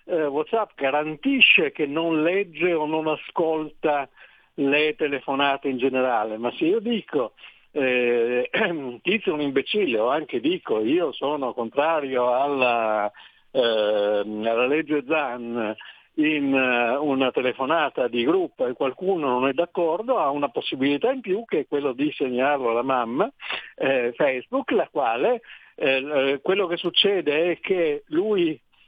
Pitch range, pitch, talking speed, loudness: 130-185 Hz, 150 Hz, 140 wpm, -23 LUFS